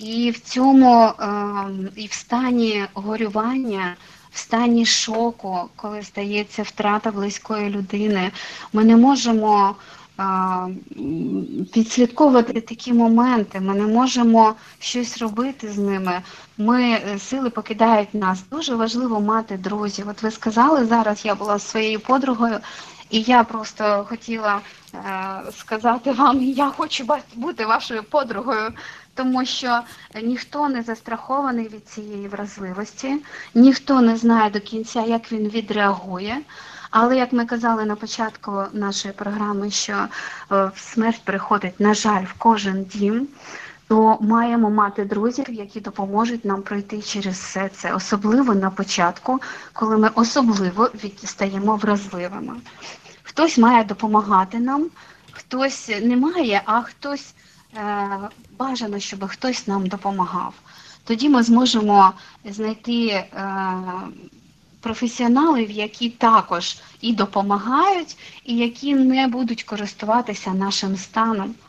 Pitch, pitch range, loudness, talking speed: 220 Hz, 200-240 Hz, -20 LUFS, 115 wpm